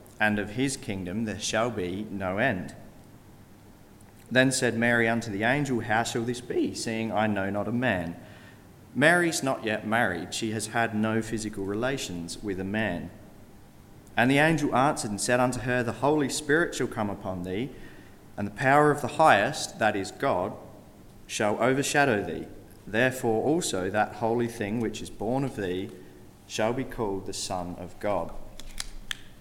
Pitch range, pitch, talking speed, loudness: 100-125 Hz, 110 Hz, 165 wpm, -27 LUFS